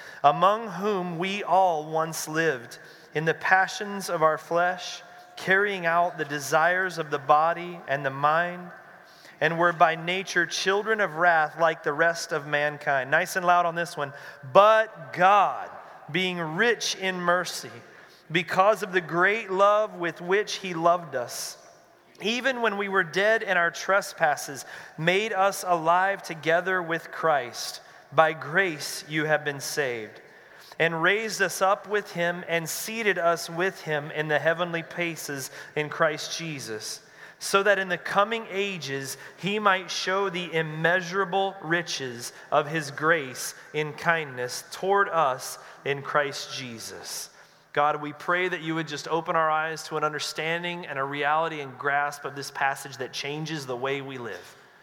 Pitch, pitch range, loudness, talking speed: 170 Hz, 150-190 Hz, -25 LUFS, 155 wpm